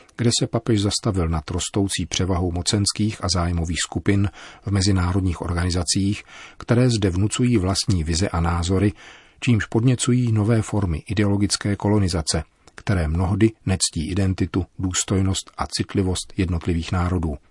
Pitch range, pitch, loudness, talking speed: 85-105 Hz, 95 Hz, -22 LUFS, 125 wpm